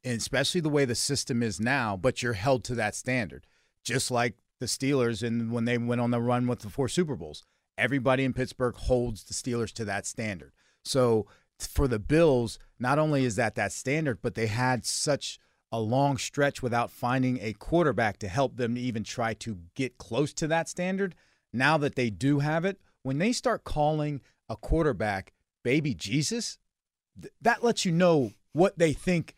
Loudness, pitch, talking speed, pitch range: -28 LUFS, 125 Hz, 190 wpm, 115-145 Hz